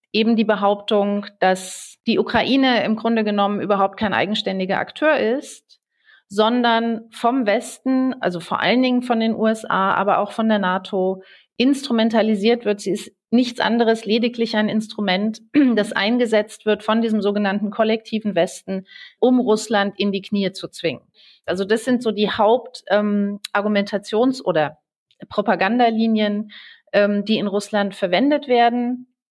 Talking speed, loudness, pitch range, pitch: 140 wpm, -20 LUFS, 200-230 Hz, 215 Hz